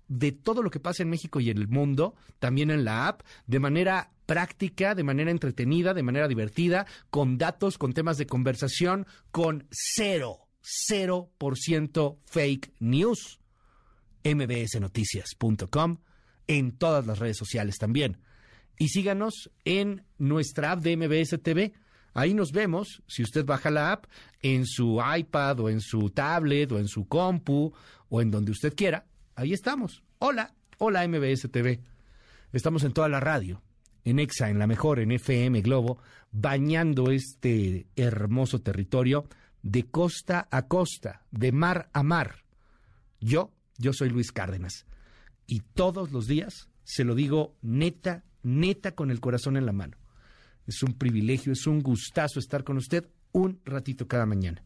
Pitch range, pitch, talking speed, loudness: 120-165 Hz, 140 Hz, 155 wpm, -28 LUFS